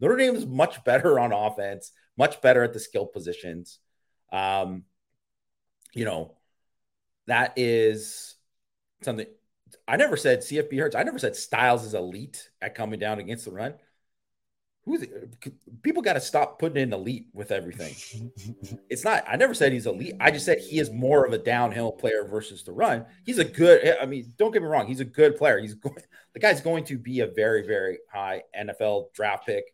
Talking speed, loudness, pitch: 190 wpm, -24 LUFS, 125 Hz